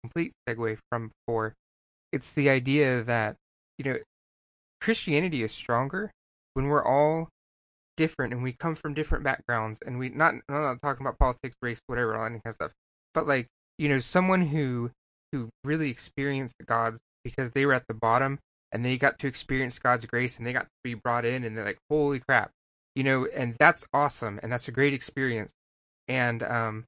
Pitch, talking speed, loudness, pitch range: 125 Hz, 190 wpm, -28 LUFS, 115-140 Hz